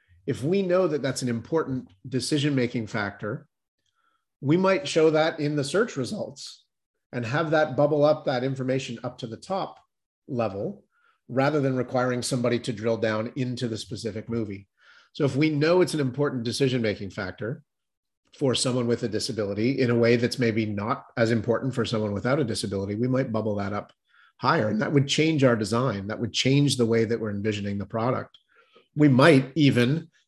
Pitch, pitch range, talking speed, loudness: 125 Hz, 115-145 Hz, 185 wpm, -25 LUFS